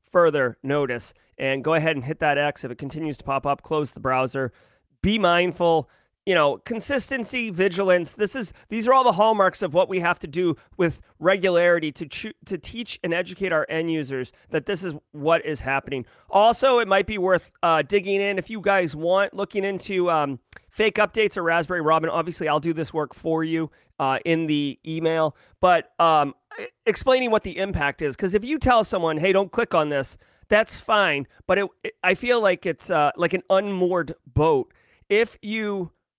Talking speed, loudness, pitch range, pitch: 195 wpm, -23 LUFS, 155-200 Hz, 175 Hz